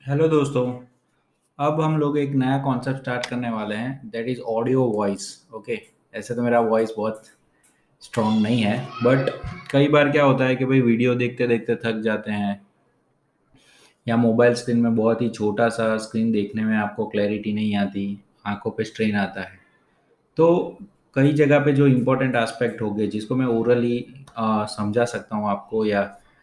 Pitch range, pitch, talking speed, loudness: 105-130 Hz, 115 Hz, 175 wpm, -22 LUFS